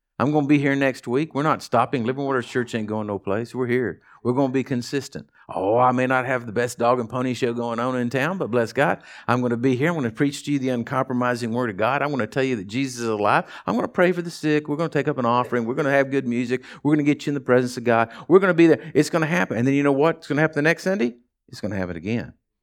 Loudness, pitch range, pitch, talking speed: -22 LUFS, 120-145 Hz, 130 Hz, 325 wpm